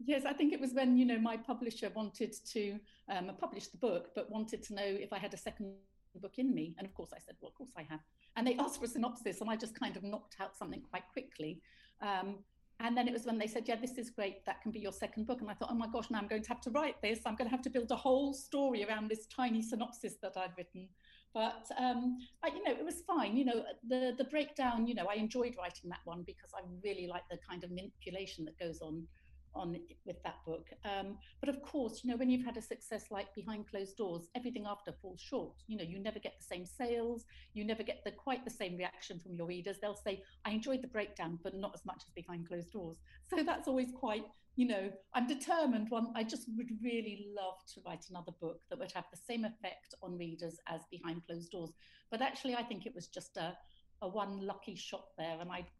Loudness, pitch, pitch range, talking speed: -40 LUFS, 215 Hz, 190-245 Hz, 250 wpm